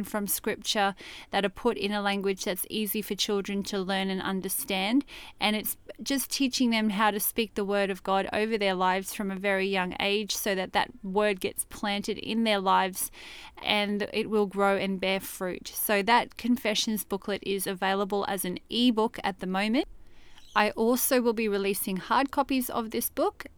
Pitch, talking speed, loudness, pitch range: 205 Hz, 190 wpm, -28 LUFS, 195-220 Hz